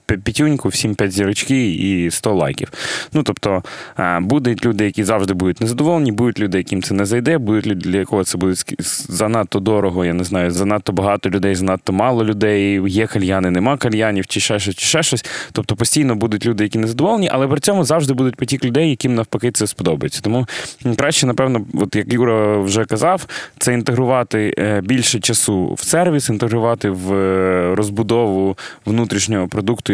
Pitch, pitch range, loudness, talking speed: 110 Hz, 100-125 Hz, -17 LUFS, 170 wpm